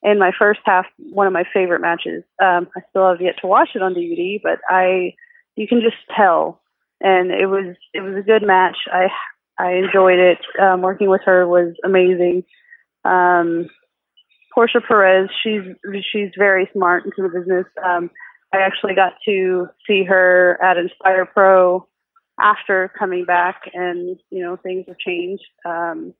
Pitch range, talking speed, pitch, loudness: 180-195 Hz, 165 wpm, 185 Hz, -16 LUFS